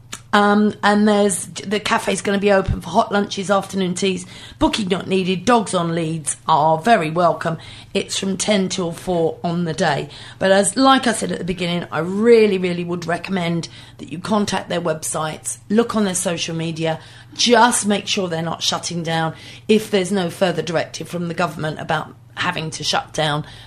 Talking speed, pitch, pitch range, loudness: 190 wpm, 175 Hz, 160-200 Hz, -19 LUFS